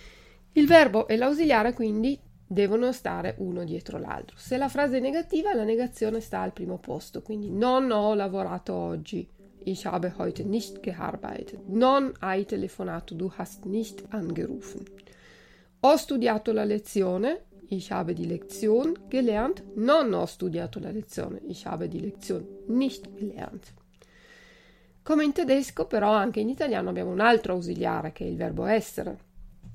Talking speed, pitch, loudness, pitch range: 150 wpm, 215 Hz, -27 LUFS, 195-250 Hz